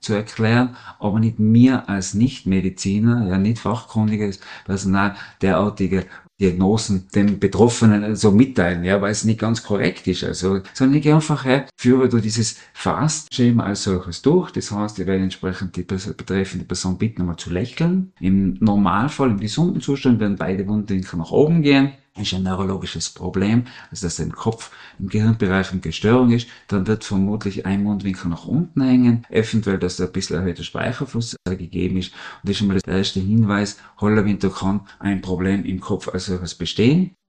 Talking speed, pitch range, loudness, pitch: 170 wpm, 95-115 Hz, -20 LUFS, 100 Hz